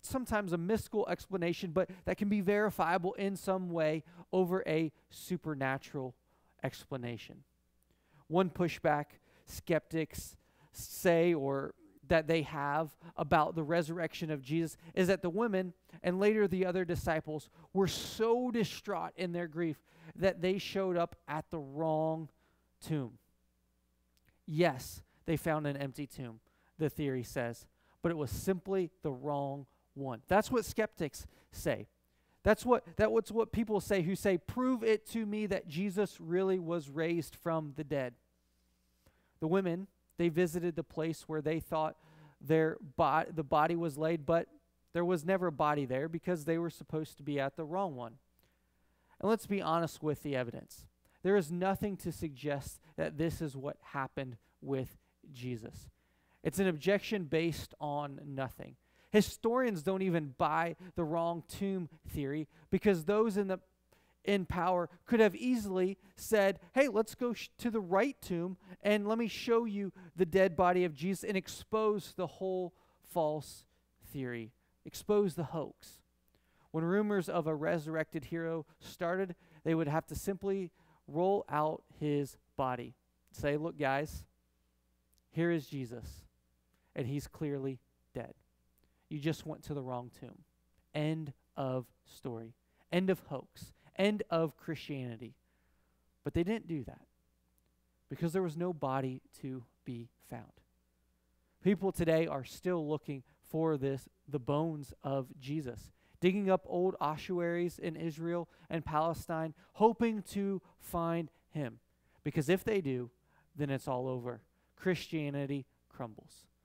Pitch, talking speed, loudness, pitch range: 160 Hz, 145 wpm, -35 LUFS, 135-185 Hz